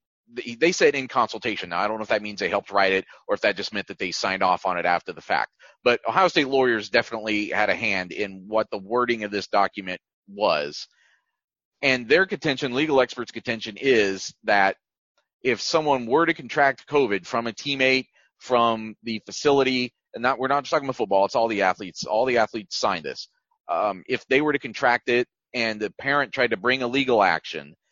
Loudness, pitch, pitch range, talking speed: -23 LUFS, 115 Hz, 100-130 Hz, 210 wpm